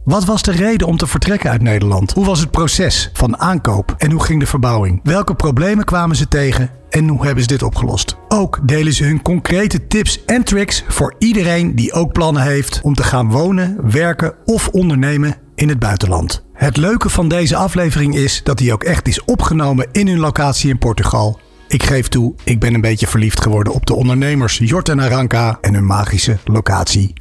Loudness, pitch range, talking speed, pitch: -14 LUFS, 115-170 Hz, 200 wpm, 140 Hz